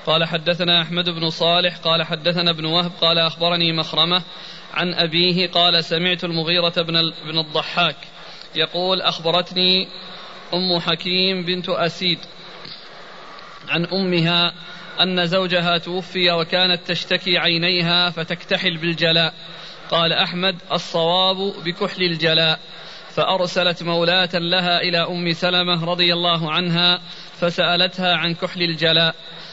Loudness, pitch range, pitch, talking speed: -18 LUFS, 165-180 Hz, 175 Hz, 110 wpm